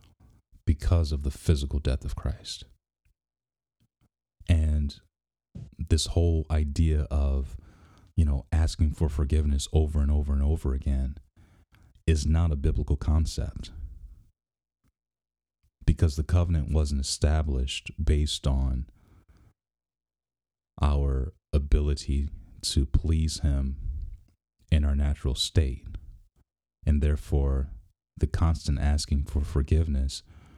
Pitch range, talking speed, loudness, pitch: 70-85 Hz, 100 wpm, -28 LUFS, 75 Hz